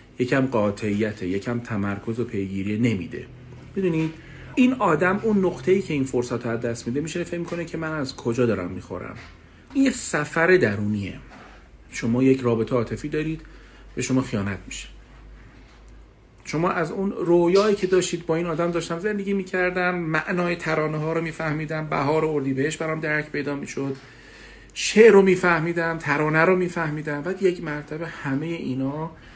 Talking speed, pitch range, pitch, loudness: 150 wpm, 120-175 Hz, 155 Hz, -23 LUFS